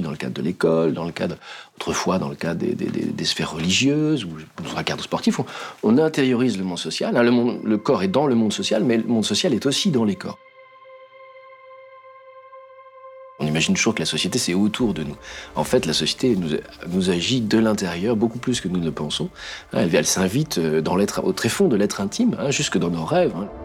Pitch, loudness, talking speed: 120 Hz, -21 LUFS, 225 wpm